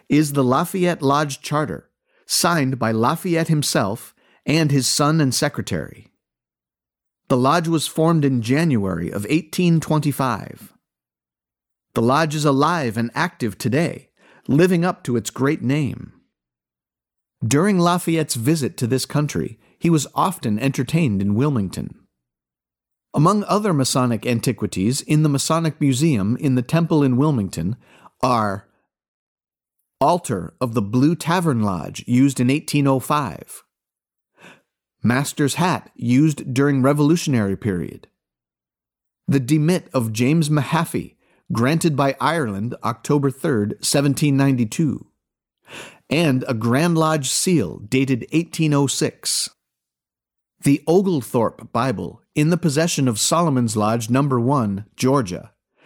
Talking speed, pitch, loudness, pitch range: 120 wpm, 135 Hz, -20 LUFS, 110-155 Hz